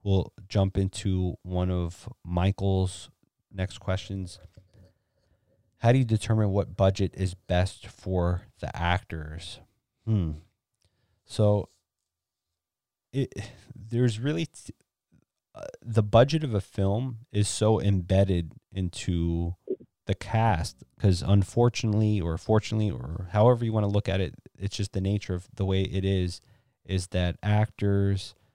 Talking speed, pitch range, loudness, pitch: 130 wpm, 90-110 Hz, -27 LUFS, 100 Hz